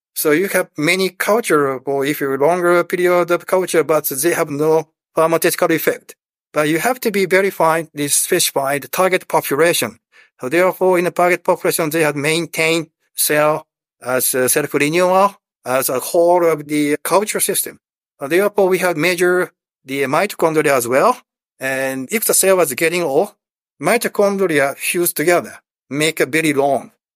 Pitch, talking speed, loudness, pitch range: 165 Hz, 160 wpm, -16 LUFS, 150-180 Hz